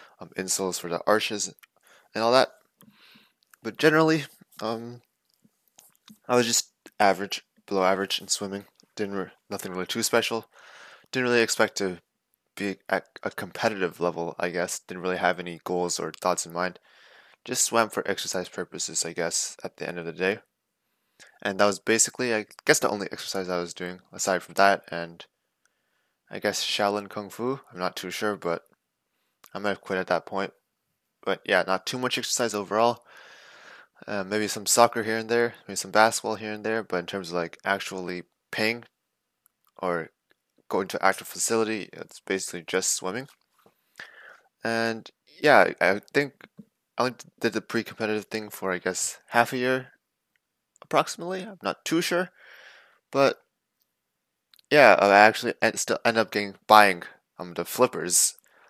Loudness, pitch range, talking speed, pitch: -25 LUFS, 95-115 Hz, 165 wpm, 105 Hz